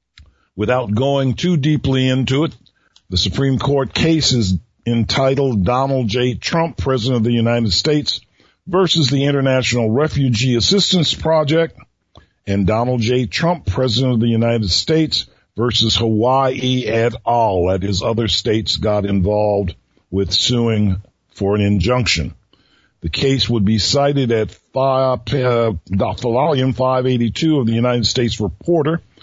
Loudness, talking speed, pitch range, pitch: -16 LUFS, 130 wpm, 105-135 Hz, 120 Hz